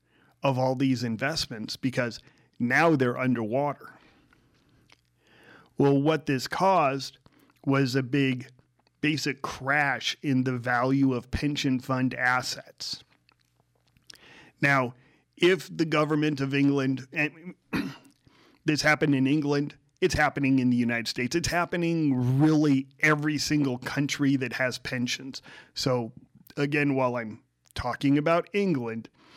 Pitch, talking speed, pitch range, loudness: 135 Hz, 115 wpm, 125-150 Hz, -26 LUFS